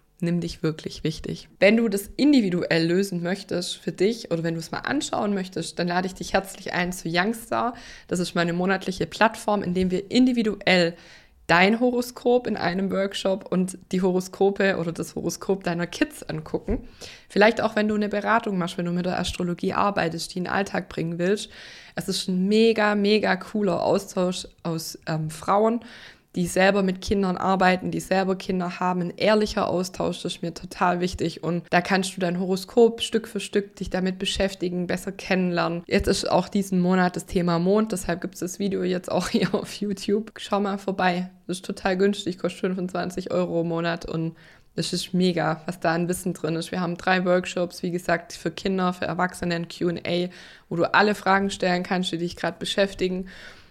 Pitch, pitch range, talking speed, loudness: 185 Hz, 175-200 Hz, 190 wpm, -24 LUFS